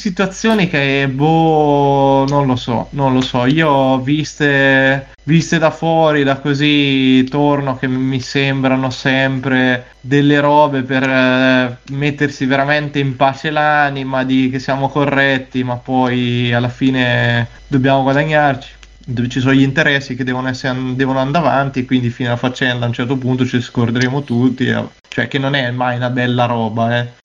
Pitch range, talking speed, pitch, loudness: 125-145 Hz, 160 wpm, 135 Hz, -14 LUFS